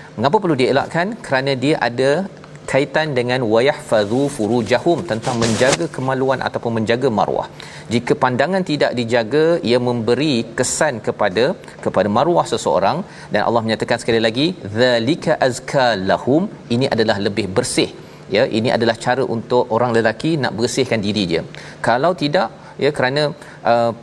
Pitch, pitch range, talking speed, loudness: 125 Hz, 115-150 Hz, 140 wpm, -18 LUFS